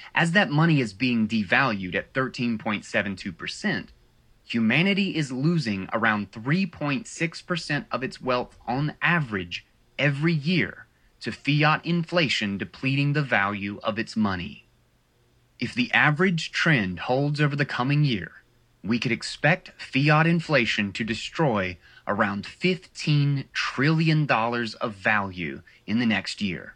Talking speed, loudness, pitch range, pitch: 120 wpm, -24 LUFS, 110-155 Hz, 130 Hz